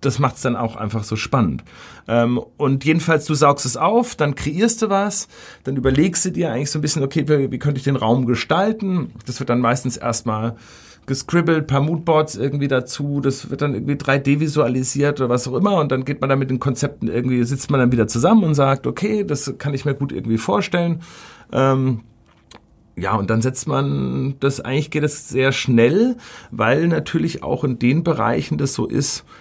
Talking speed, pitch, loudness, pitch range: 205 wpm, 135 Hz, -19 LUFS, 125-155 Hz